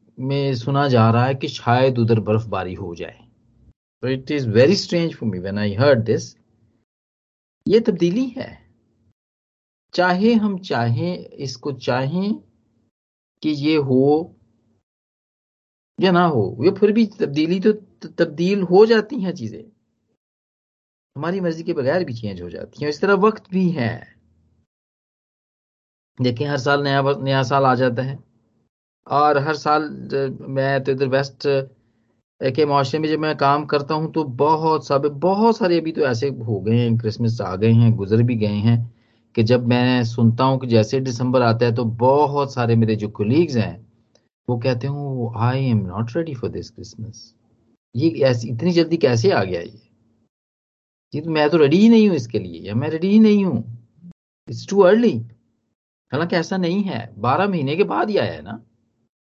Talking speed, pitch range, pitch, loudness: 165 wpm, 115-155 Hz, 130 Hz, -19 LUFS